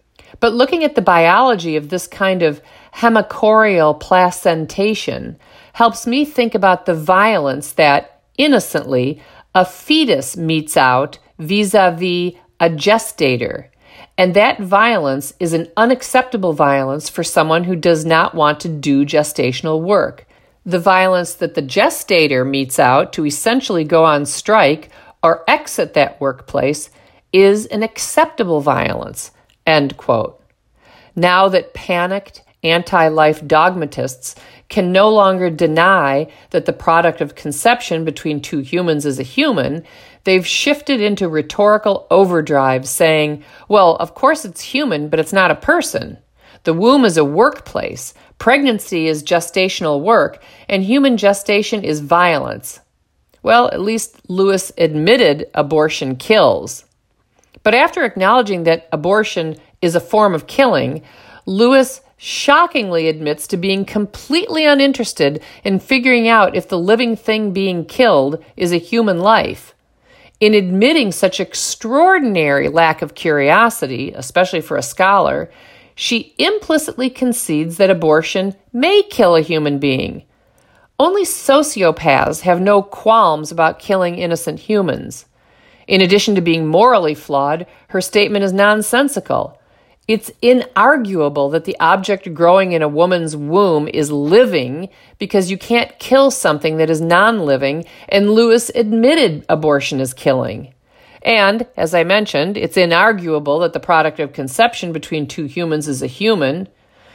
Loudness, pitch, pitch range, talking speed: -14 LUFS, 180 Hz, 155-220 Hz, 135 wpm